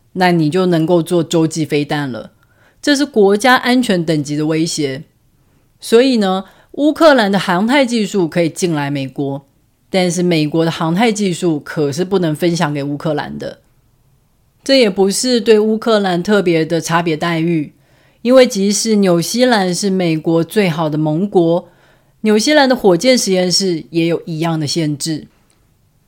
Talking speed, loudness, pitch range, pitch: 240 characters per minute, -14 LUFS, 150-205 Hz, 170 Hz